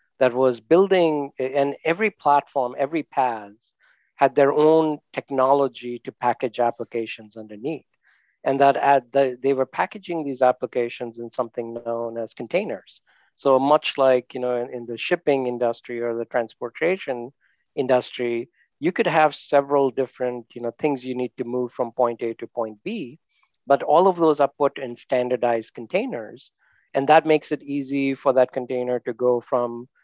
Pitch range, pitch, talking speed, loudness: 120-140 Hz, 130 Hz, 160 wpm, -22 LUFS